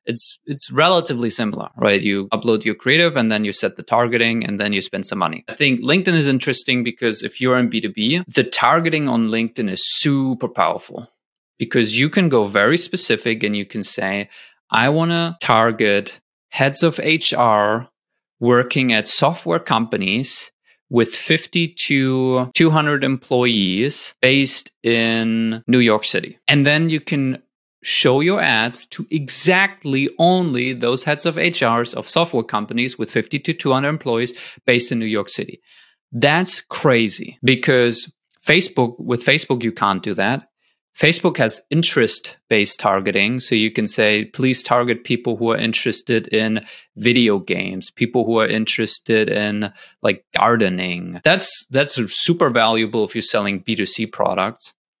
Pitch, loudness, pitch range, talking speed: 125 Hz, -17 LUFS, 110-145 Hz, 155 wpm